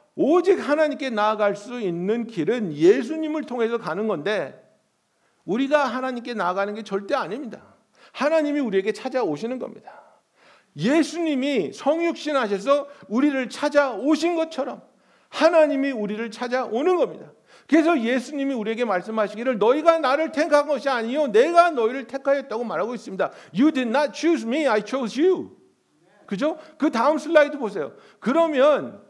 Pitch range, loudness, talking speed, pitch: 230-305 Hz, -22 LUFS, 370 characters per minute, 275 Hz